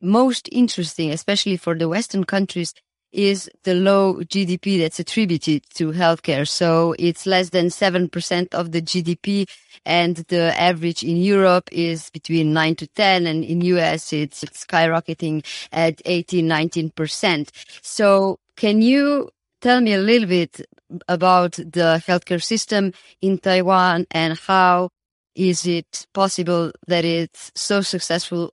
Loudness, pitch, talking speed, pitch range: -19 LUFS, 175 Hz, 135 wpm, 165-195 Hz